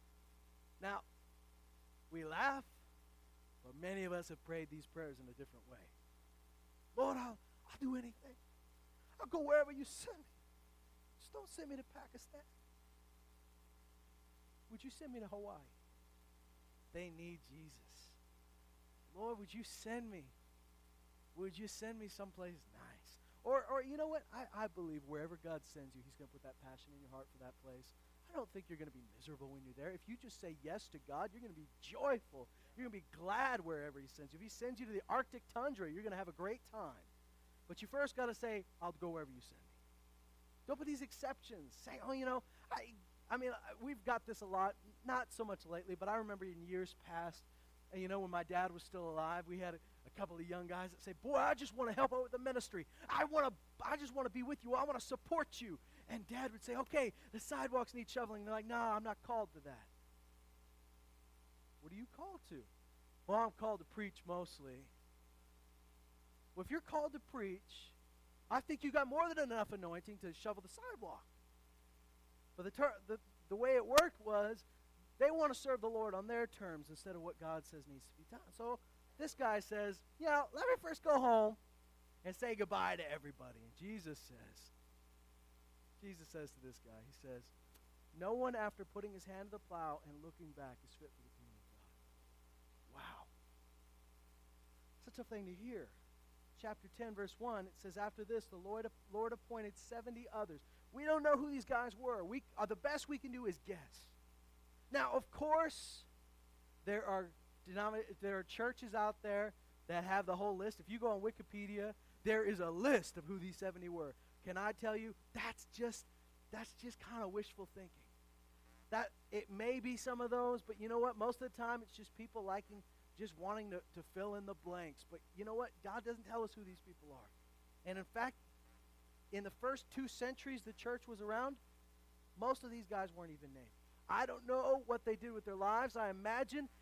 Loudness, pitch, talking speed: -44 LUFS, 190 Hz, 205 wpm